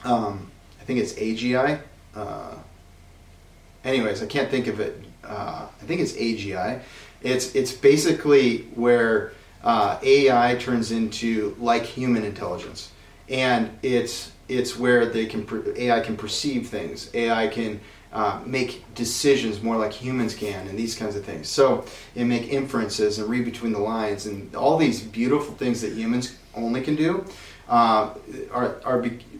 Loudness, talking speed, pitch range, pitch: -24 LUFS, 155 wpm, 105-125 Hz, 115 Hz